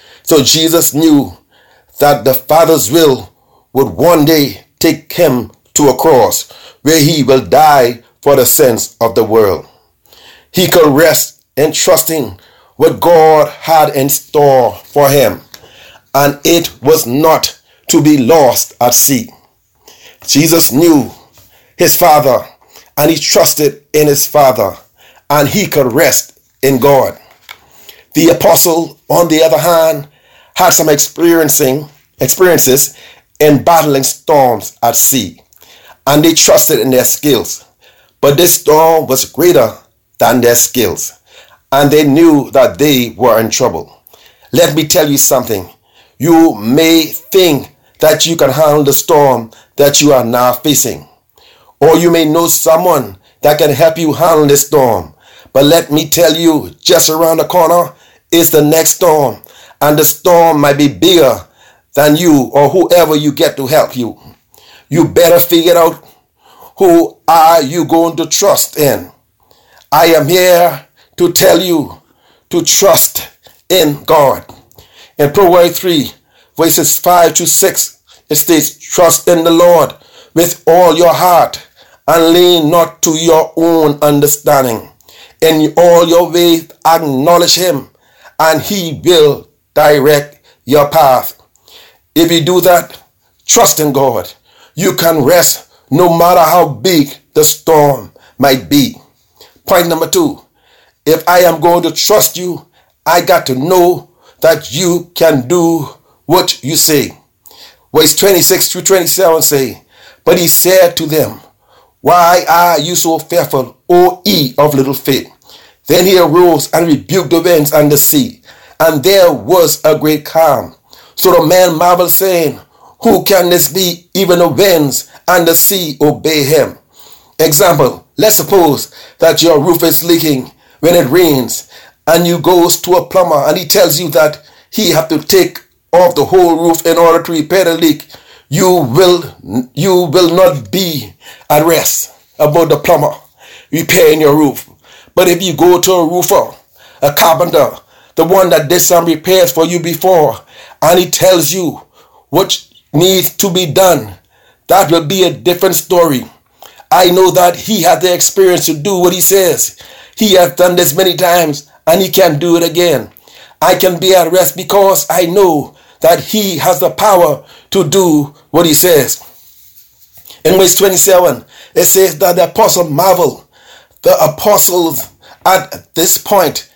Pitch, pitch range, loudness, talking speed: 165 Hz, 150-180 Hz, -9 LUFS, 150 wpm